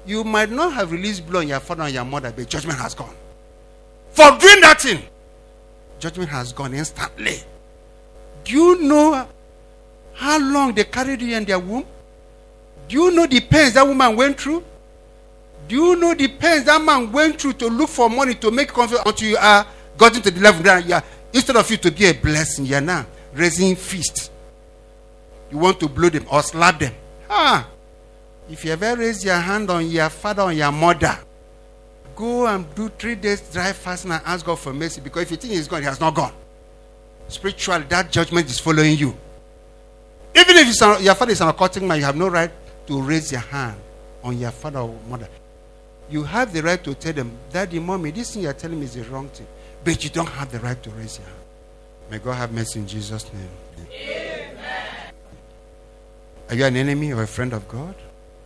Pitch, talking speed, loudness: 160 Hz, 210 wpm, -17 LUFS